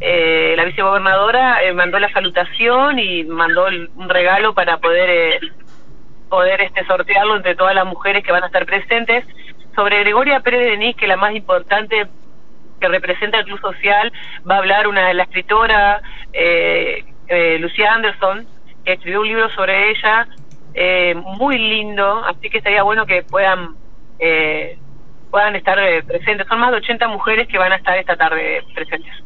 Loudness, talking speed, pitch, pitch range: -14 LUFS, 170 wpm, 200 Hz, 185-225 Hz